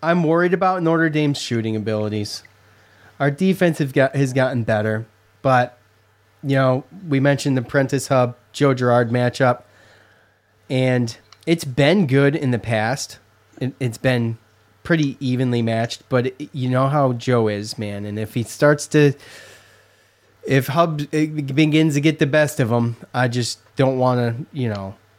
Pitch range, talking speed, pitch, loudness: 110-145 Hz, 160 wpm, 125 Hz, -20 LUFS